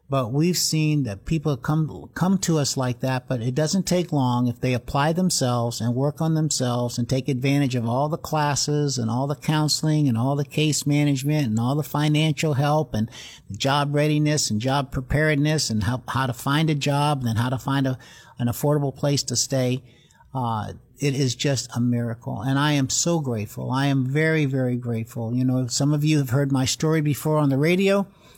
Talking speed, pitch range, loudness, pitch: 205 wpm, 125-150 Hz, -23 LUFS, 140 Hz